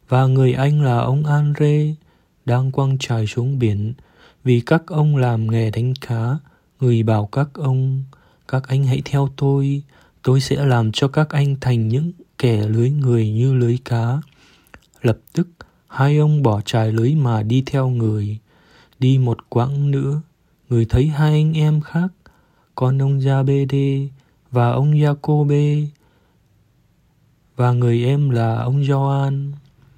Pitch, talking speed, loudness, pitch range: 135 Hz, 150 wpm, -18 LUFS, 120-140 Hz